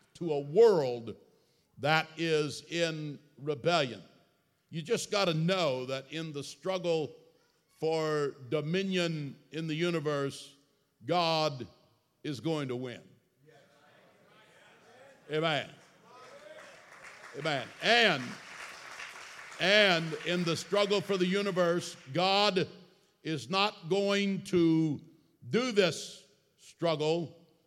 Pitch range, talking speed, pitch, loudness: 150-190 Hz, 95 wpm, 165 Hz, -30 LUFS